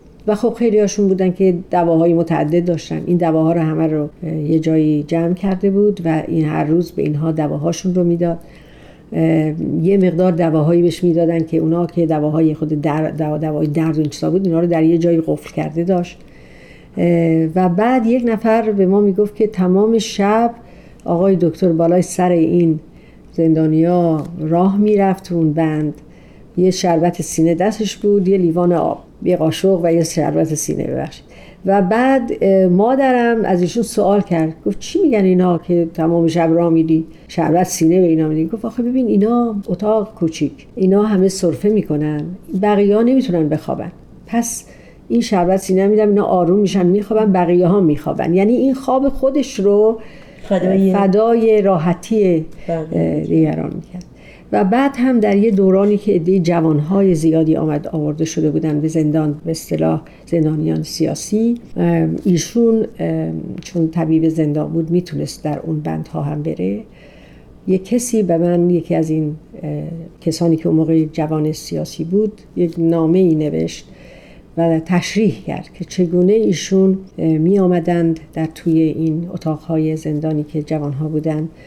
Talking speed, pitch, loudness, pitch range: 150 wpm, 170 Hz, -16 LUFS, 160-195 Hz